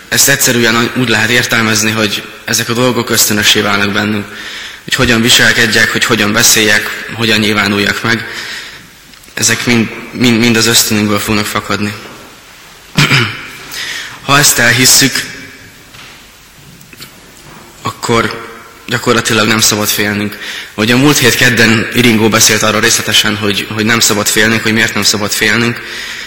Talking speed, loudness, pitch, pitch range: 130 wpm, -9 LUFS, 115 Hz, 105-115 Hz